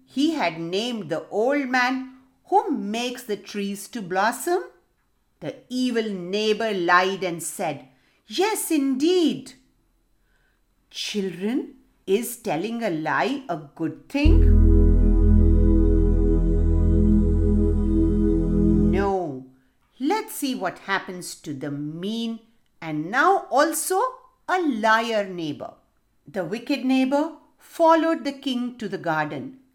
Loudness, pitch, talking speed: -23 LUFS, 205 Hz, 105 wpm